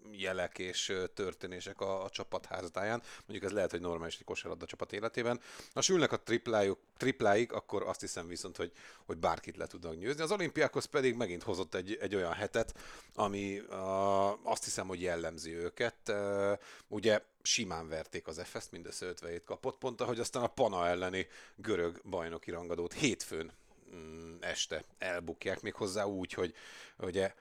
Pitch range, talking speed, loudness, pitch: 85-105 Hz, 160 wpm, -36 LUFS, 95 Hz